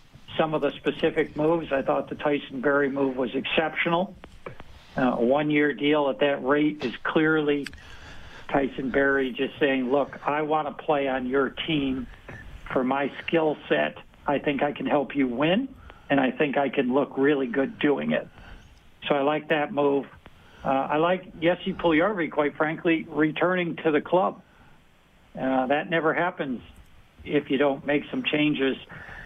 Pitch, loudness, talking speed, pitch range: 145 Hz, -25 LUFS, 165 wpm, 135-155 Hz